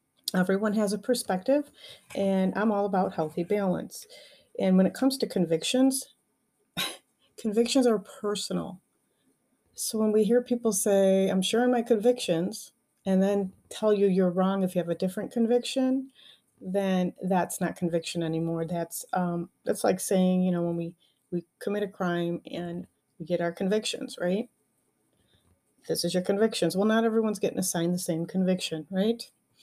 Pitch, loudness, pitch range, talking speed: 195 Hz, -27 LUFS, 175-225 Hz, 160 wpm